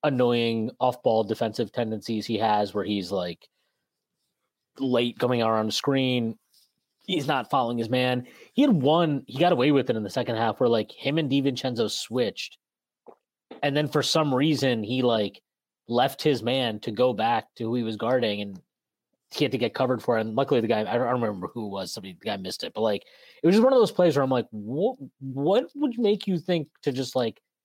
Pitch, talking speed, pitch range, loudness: 125 Hz, 215 wpm, 115-145 Hz, -25 LUFS